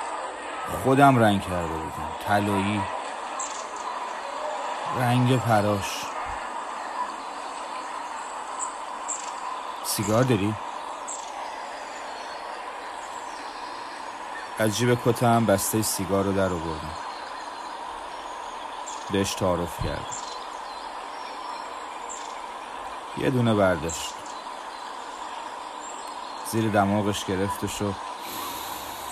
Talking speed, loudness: 60 wpm, -28 LUFS